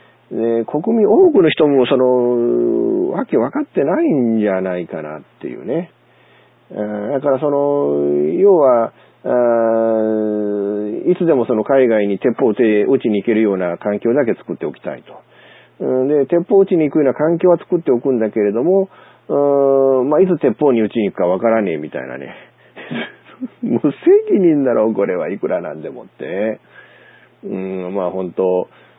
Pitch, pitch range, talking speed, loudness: 120 Hz, 105-145 Hz, 300 characters per minute, -16 LUFS